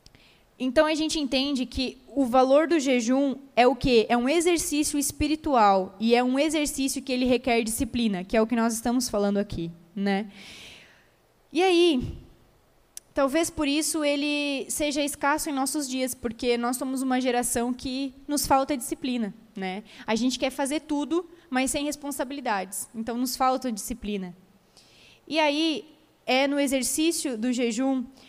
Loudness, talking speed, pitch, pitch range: -25 LUFS, 155 wpm, 265 Hz, 240-290 Hz